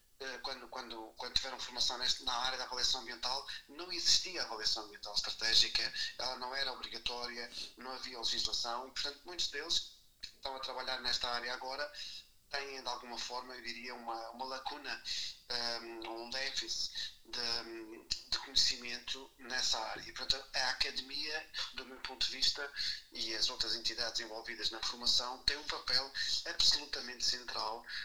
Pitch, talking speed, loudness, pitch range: 125 Hz, 150 wpm, -36 LUFS, 115-130 Hz